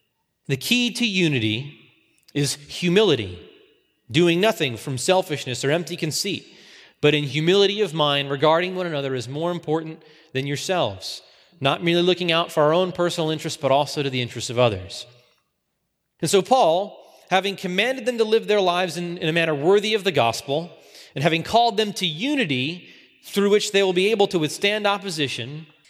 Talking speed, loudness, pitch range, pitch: 175 wpm, -21 LUFS, 145-195 Hz, 165 Hz